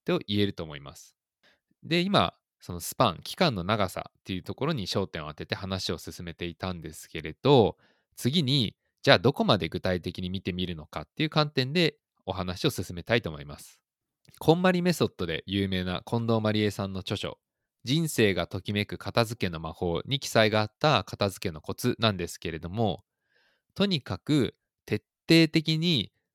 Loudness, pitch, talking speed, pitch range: -28 LUFS, 100 Hz, 340 characters per minute, 90-125 Hz